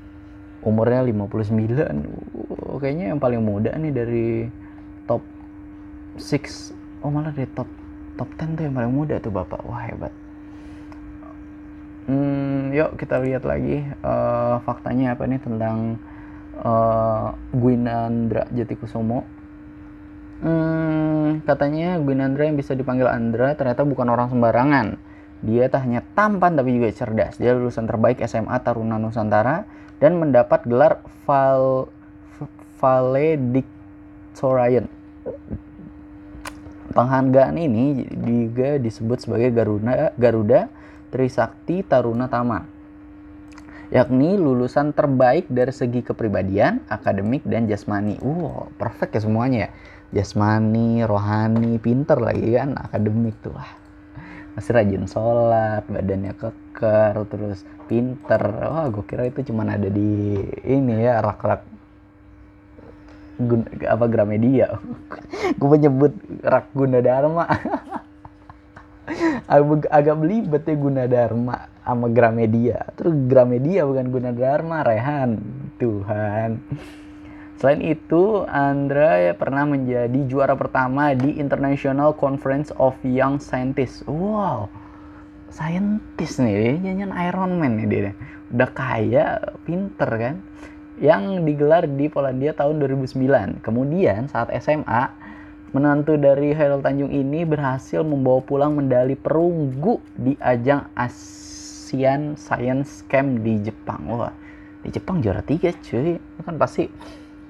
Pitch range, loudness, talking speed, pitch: 100-140 Hz, -21 LUFS, 115 wpm, 120 Hz